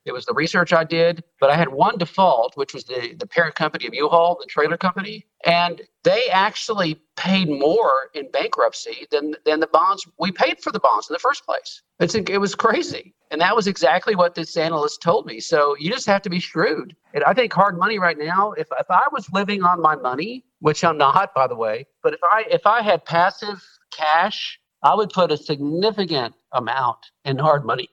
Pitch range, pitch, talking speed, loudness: 155-205 Hz, 175 Hz, 215 wpm, -20 LUFS